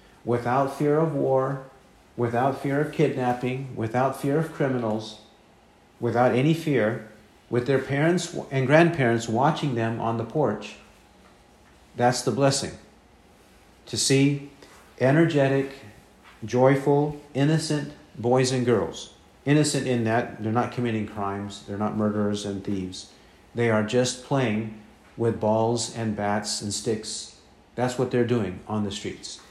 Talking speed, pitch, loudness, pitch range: 130 wpm, 120 Hz, -25 LUFS, 110-140 Hz